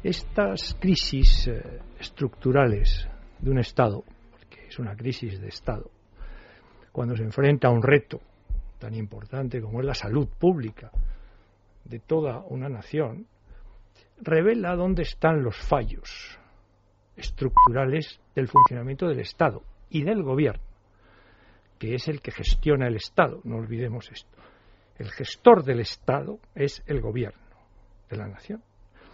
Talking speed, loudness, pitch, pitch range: 130 wpm, -25 LUFS, 125 Hz, 105-150 Hz